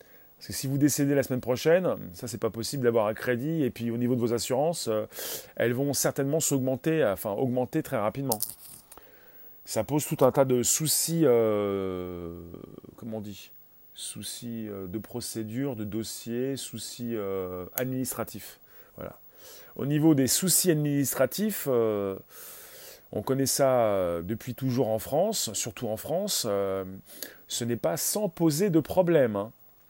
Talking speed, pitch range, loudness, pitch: 155 wpm, 110-145 Hz, -27 LUFS, 125 Hz